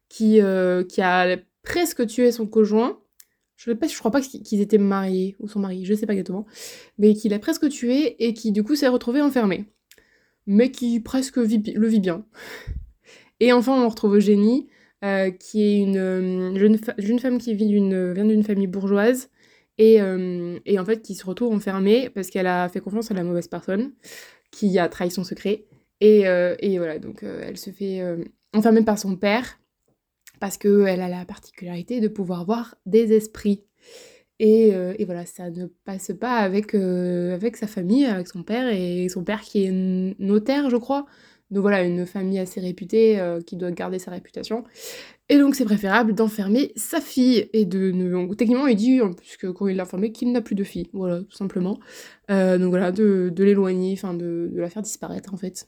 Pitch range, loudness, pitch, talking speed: 185-230 Hz, -21 LUFS, 205 Hz, 200 wpm